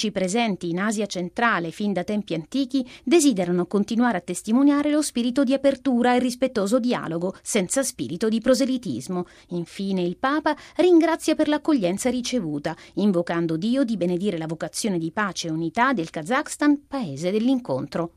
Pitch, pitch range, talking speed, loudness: 220 Hz, 175-265 Hz, 145 wpm, -23 LUFS